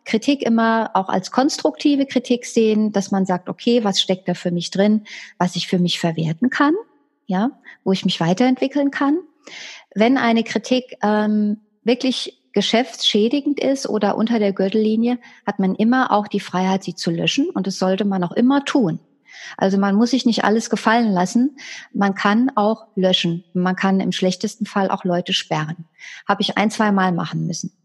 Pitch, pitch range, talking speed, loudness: 210 Hz, 190-245 Hz, 175 wpm, -19 LUFS